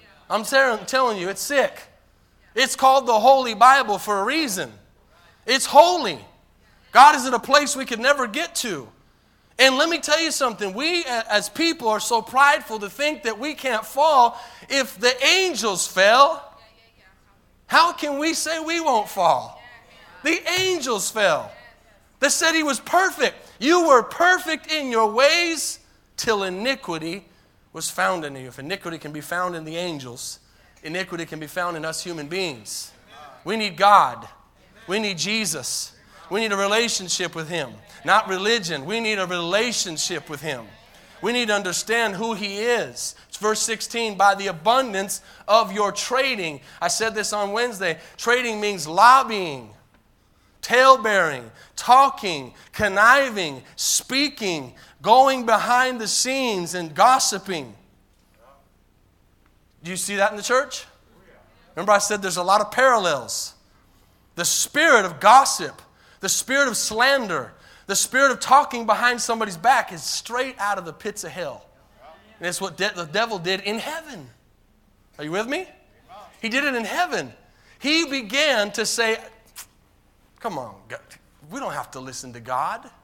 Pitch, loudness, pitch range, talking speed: 215 Hz, -20 LUFS, 180-265 Hz, 155 wpm